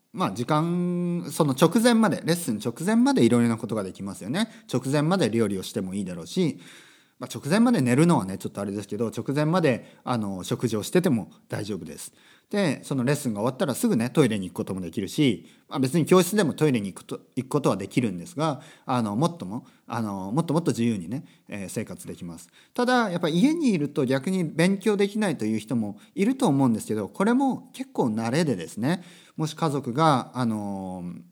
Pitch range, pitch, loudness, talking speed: 115-190 Hz, 150 Hz, -25 LUFS, 420 characters per minute